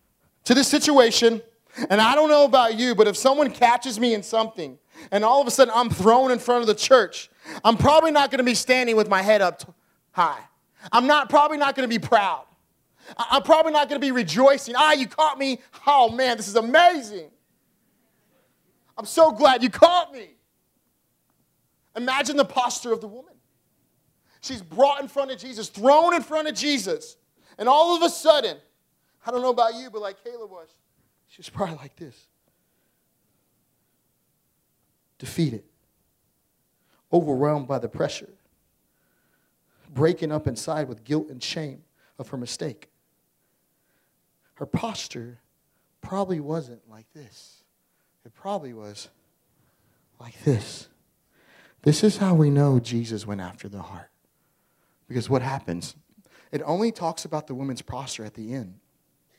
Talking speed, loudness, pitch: 165 wpm, -21 LUFS, 220 Hz